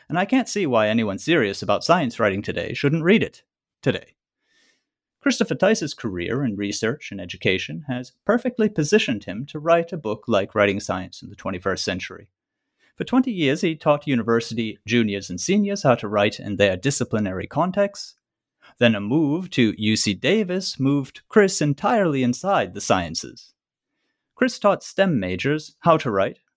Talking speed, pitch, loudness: 165 wpm, 140 Hz, -22 LUFS